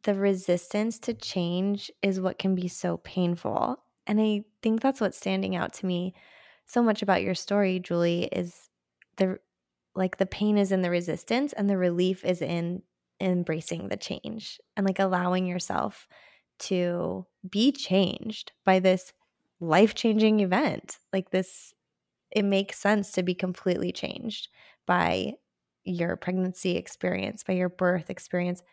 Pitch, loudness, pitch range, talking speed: 185 Hz, -28 LUFS, 180-205 Hz, 145 wpm